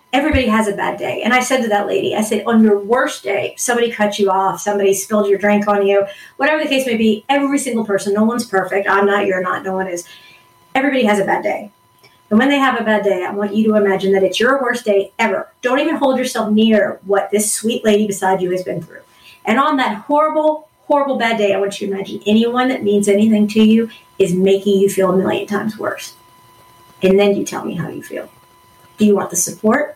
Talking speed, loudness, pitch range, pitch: 240 wpm, -16 LUFS, 195-240 Hz, 210 Hz